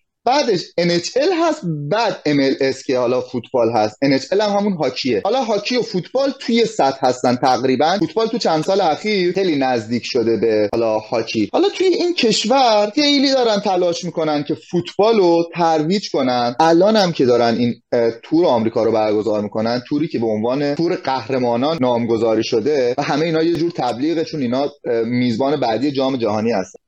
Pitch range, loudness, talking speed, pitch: 125-195 Hz, -17 LUFS, 170 wpm, 155 Hz